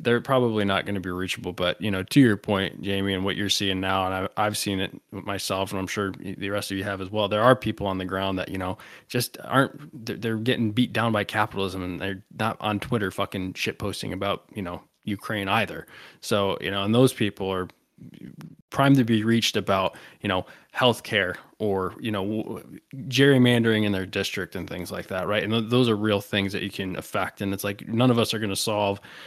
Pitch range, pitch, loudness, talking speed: 95-115 Hz, 100 Hz, -25 LUFS, 230 wpm